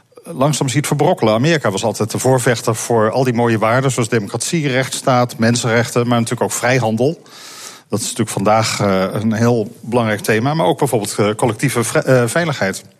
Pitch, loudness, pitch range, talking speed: 120 Hz, -16 LUFS, 110-130 Hz, 155 wpm